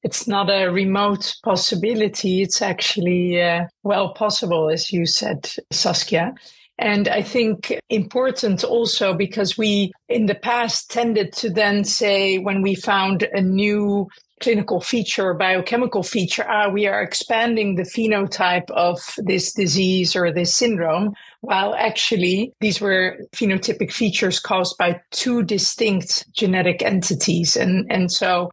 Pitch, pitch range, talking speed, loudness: 200 Hz, 185-220 Hz, 135 wpm, -19 LUFS